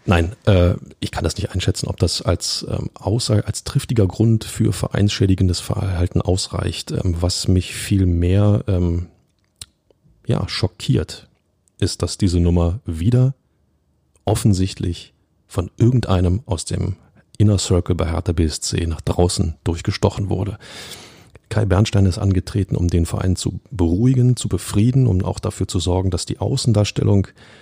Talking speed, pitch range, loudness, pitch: 130 wpm, 90-110 Hz, -19 LUFS, 95 Hz